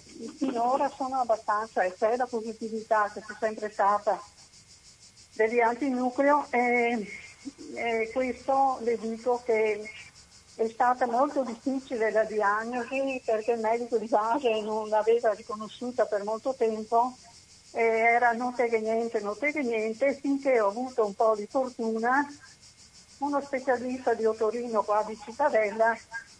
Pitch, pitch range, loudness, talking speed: 230 Hz, 220-255 Hz, -28 LUFS, 130 wpm